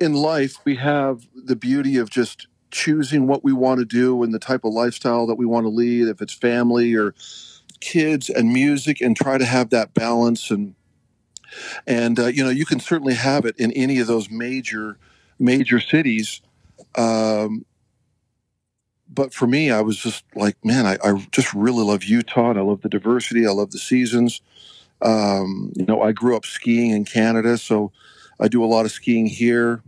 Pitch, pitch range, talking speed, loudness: 120 Hz, 110-130 Hz, 190 wpm, -19 LUFS